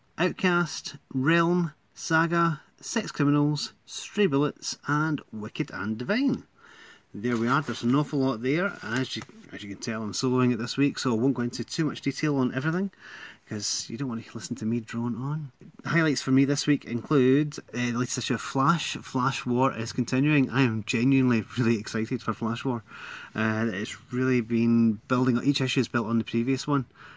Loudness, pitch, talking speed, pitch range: -27 LUFS, 130 Hz, 195 wpm, 115-145 Hz